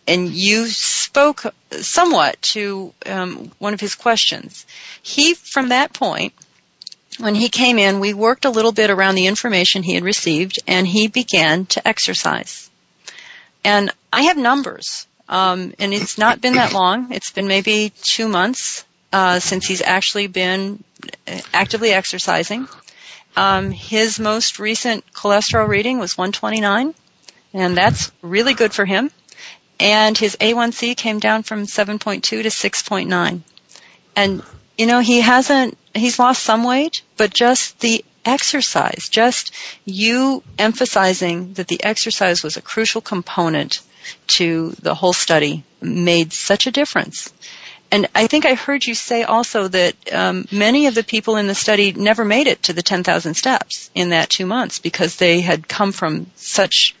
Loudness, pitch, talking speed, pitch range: -16 LUFS, 215 Hz, 155 wpm, 190-240 Hz